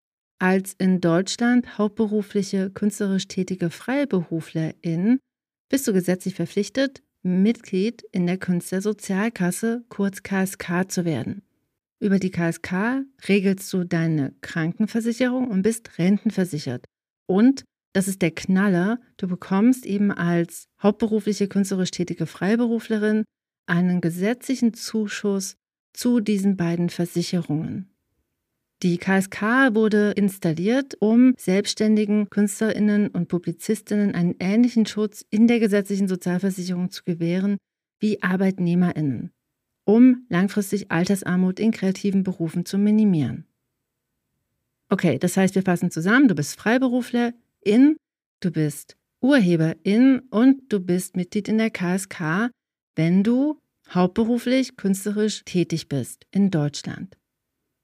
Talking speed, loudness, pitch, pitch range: 110 wpm, -22 LUFS, 200 Hz, 180-220 Hz